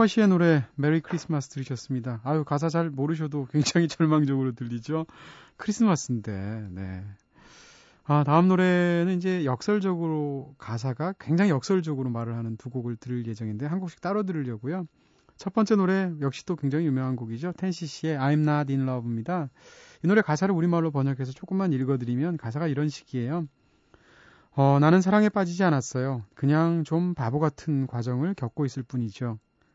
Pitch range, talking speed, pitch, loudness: 130-170 Hz, 385 characters per minute, 150 Hz, -26 LUFS